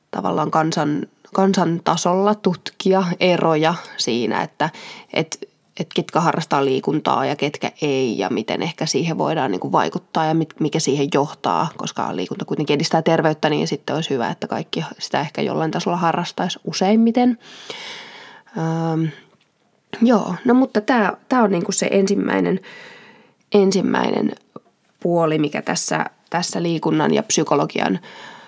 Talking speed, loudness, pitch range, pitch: 135 wpm, -20 LUFS, 155-210 Hz, 175 Hz